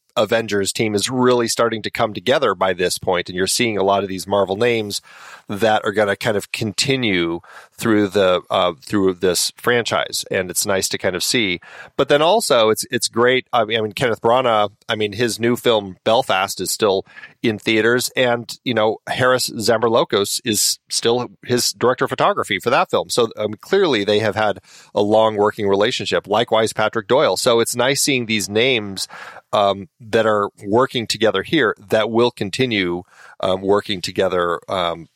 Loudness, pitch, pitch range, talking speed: -18 LUFS, 110 Hz, 100-120 Hz, 185 wpm